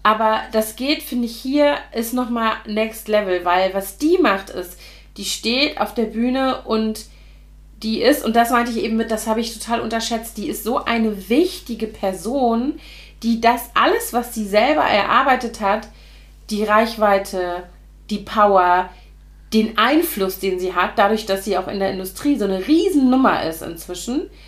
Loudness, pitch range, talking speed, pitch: -19 LUFS, 200-240 Hz, 170 wpm, 220 Hz